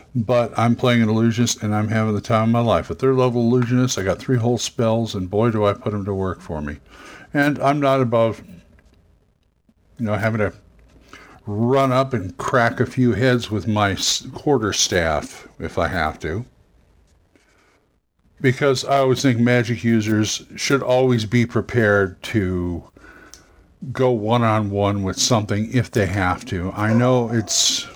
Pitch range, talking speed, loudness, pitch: 100-125 Hz, 170 wpm, -19 LUFS, 115 Hz